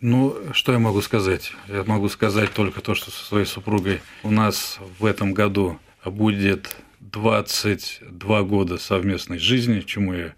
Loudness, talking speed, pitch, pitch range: -22 LUFS, 150 wpm, 100 Hz, 95-110 Hz